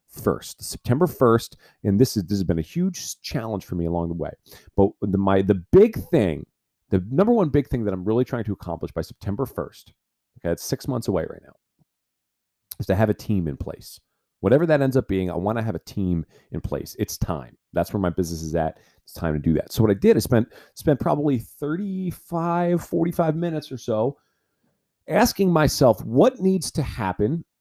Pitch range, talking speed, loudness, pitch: 95-155 Hz, 210 wpm, -23 LUFS, 110 Hz